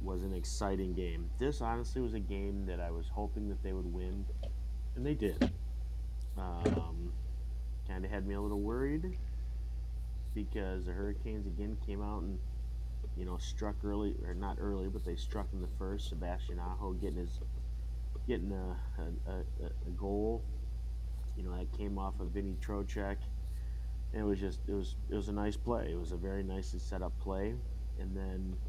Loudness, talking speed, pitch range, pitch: -39 LUFS, 180 wpm, 60-95 Hz, 85 Hz